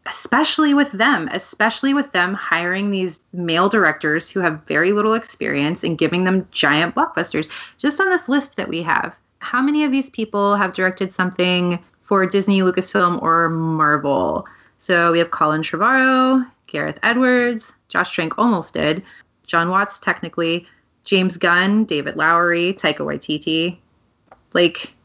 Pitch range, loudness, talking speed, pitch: 170-220 Hz, -18 LUFS, 145 wpm, 185 Hz